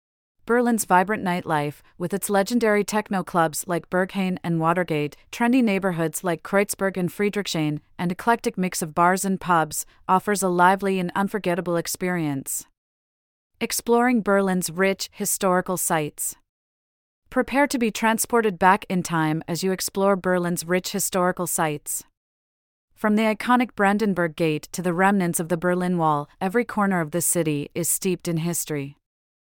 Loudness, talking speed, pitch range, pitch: -23 LUFS, 145 wpm, 170-200 Hz, 185 Hz